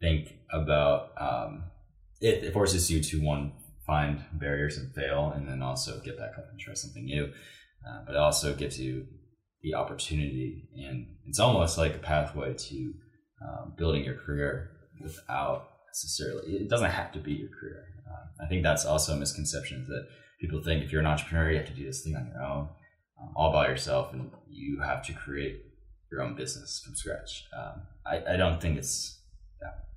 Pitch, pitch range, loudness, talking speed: 75 Hz, 70-80 Hz, -31 LUFS, 190 wpm